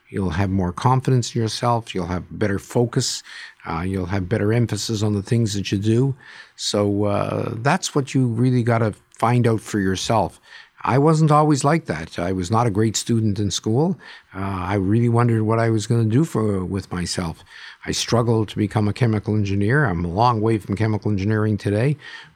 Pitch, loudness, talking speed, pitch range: 110 Hz, -21 LUFS, 195 wpm, 100-120 Hz